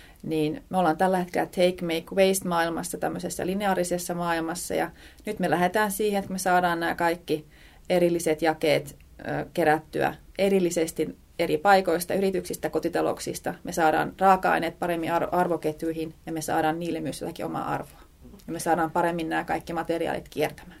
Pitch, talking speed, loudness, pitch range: 170 Hz, 145 wpm, -26 LUFS, 160-180 Hz